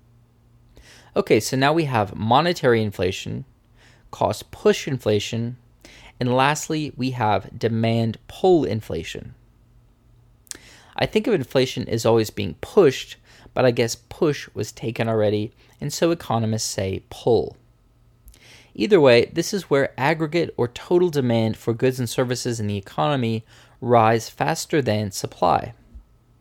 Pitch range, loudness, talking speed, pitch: 115-135 Hz, -22 LUFS, 130 wpm, 120 Hz